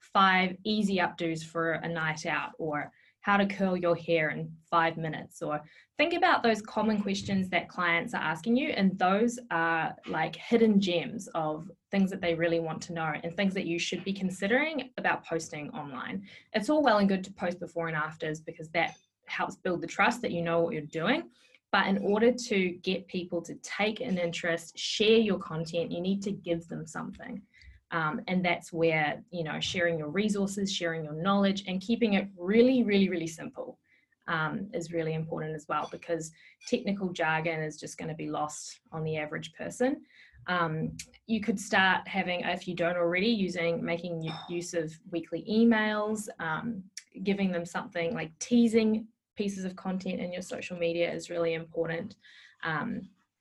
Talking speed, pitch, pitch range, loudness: 180 wpm, 180 Hz, 165-205 Hz, -30 LUFS